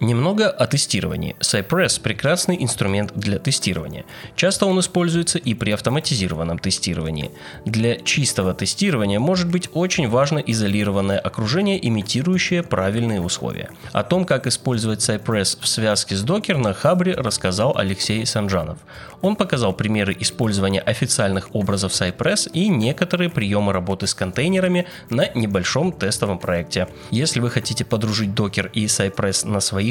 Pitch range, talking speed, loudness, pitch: 100-155 Hz, 135 wpm, -20 LUFS, 110 Hz